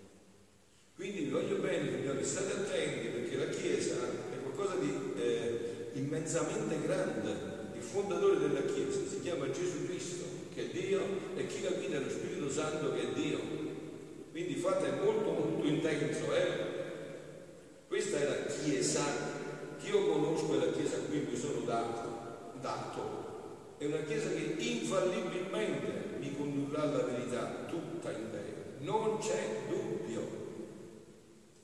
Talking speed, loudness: 140 wpm, -36 LUFS